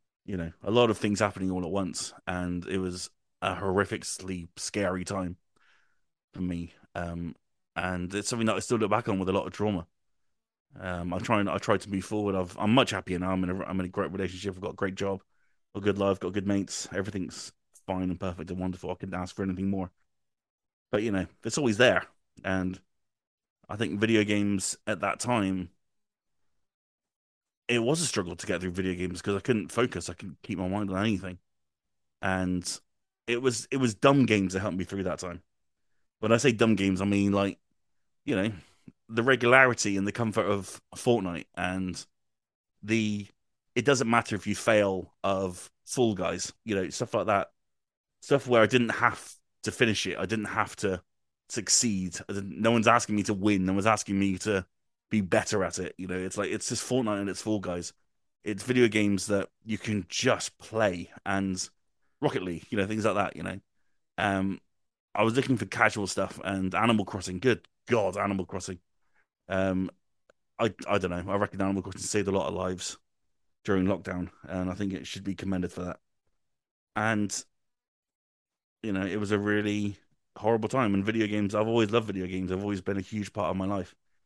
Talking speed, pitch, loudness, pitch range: 200 wpm, 100 Hz, -29 LUFS, 90-105 Hz